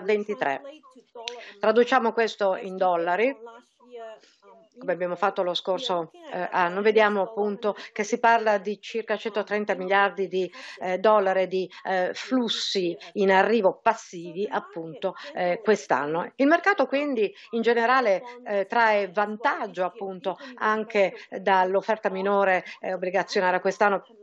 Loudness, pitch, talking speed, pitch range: -25 LUFS, 205 Hz, 120 wpm, 185-230 Hz